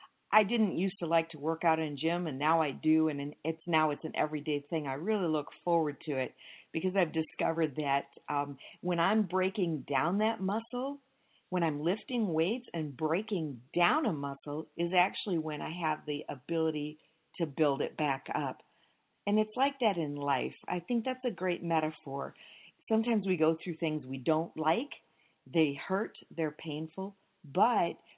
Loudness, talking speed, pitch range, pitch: -32 LUFS, 180 wpm, 155-185 Hz, 165 Hz